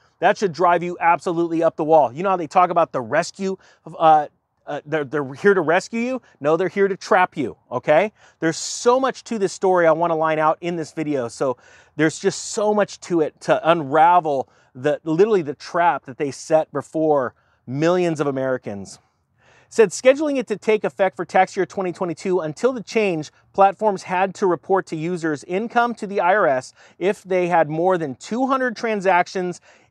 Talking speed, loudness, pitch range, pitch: 195 wpm, -20 LUFS, 155-195 Hz, 175 Hz